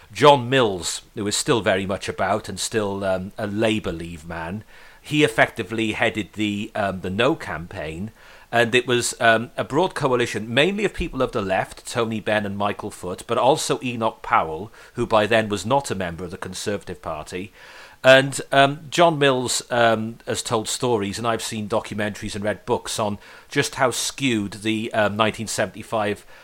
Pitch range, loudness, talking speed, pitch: 100-120 Hz, -22 LUFS, 175 wpm, 110 Hz